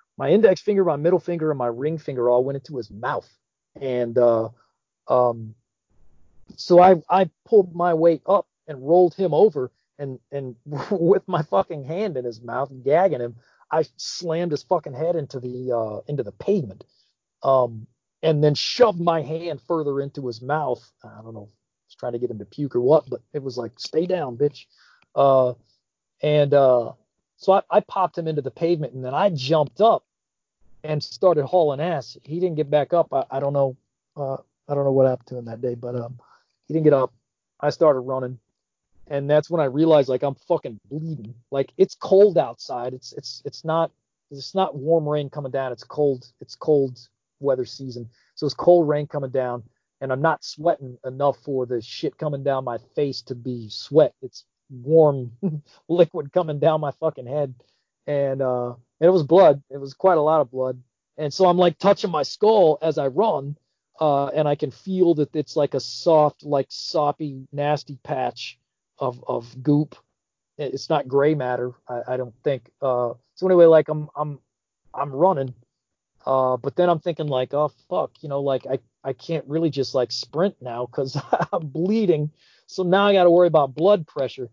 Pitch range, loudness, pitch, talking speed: 125-160 Hz, -22 LUFS, 140 Hz, 195 wpm